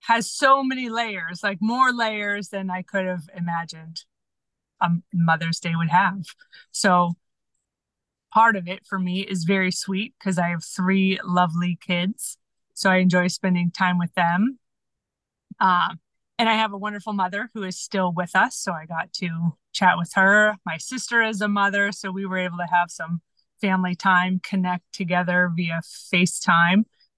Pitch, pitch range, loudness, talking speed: 185 Hz, 175-205 Hz, -22 LUFS, 170 wpm